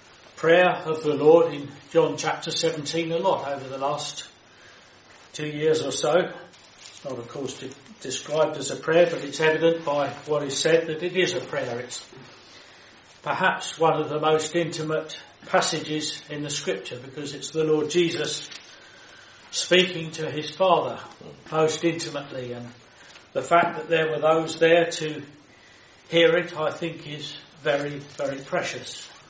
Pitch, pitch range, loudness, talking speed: 155 Hz, 145-165 Hz, -24 LUFS, 160 wpm